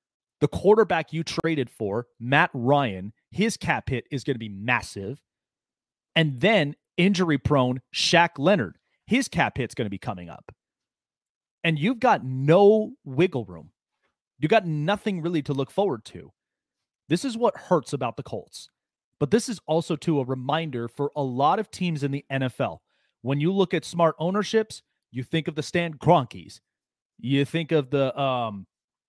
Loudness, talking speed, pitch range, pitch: -24 LUFS, 170 wpm, 130-175 Hz, 150 Hz